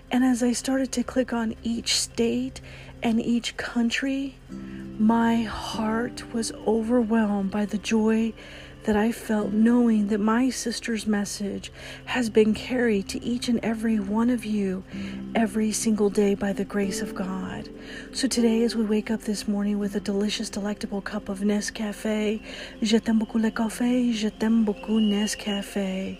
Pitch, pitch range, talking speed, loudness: 220 Hz, 210-235 Hz, 160 wpm, -25 LUFS